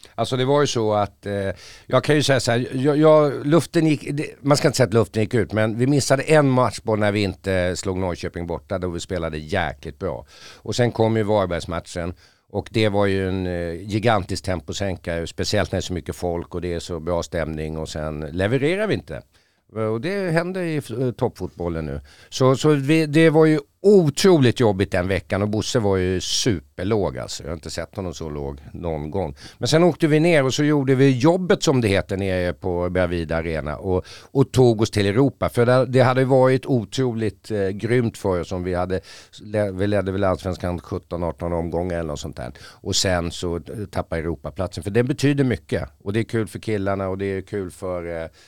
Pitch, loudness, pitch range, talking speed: 100 Hz, -21 LUFS, 90-125 Hz, 210 wpm